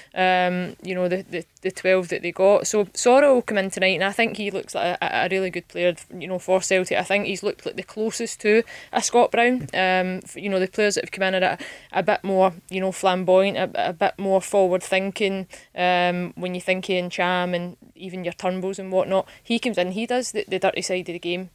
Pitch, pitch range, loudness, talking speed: 190 Hz, 180-200 Hz, -22 LUFS, 245 wpm